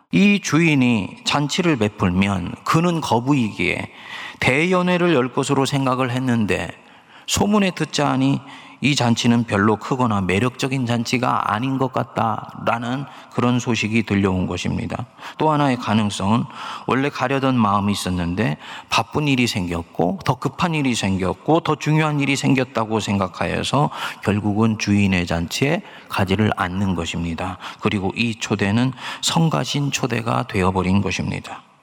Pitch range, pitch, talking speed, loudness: 100-140 Hz, 120 Hz, 305 characters per minute, -20 LUFS